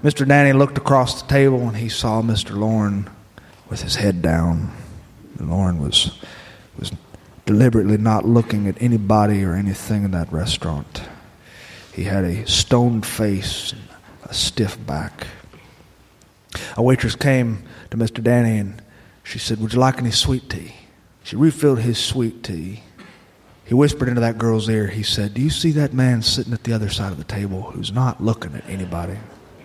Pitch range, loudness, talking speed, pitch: 100-120 Hz, -19 LUFS, 170 wpm, 110 Hz